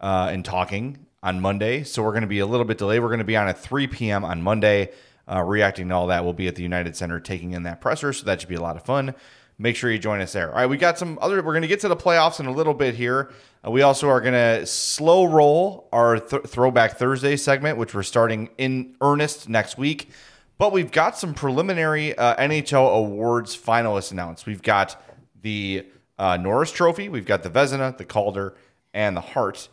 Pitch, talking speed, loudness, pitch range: 120 Hz, 235 wpm, -22 LUFS, 100-140 Hz